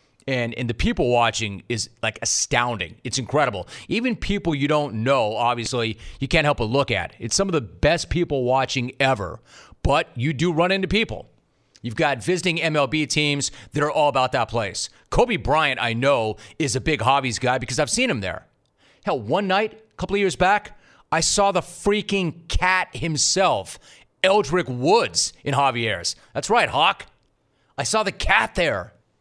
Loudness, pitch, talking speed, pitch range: -22 LUFS, 140 Hz, 180 wpm, 120-175 Hz